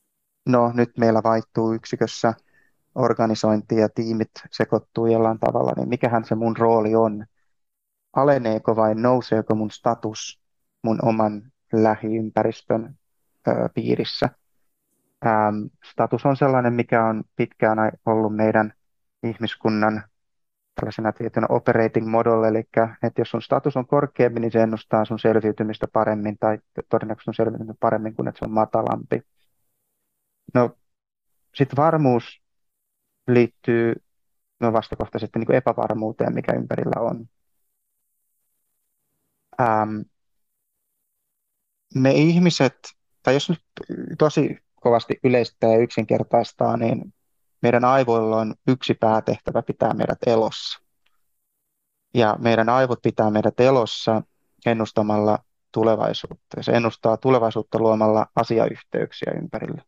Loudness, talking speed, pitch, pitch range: -21 LUFS, 110 wpm, 115 Hz, 110-120 Hz